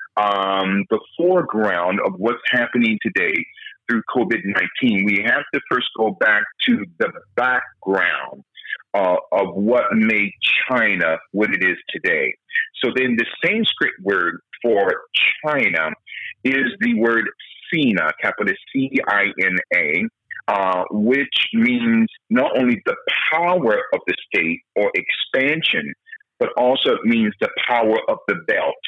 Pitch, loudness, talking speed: 170 Hz, -19 LUFS, 125 wpm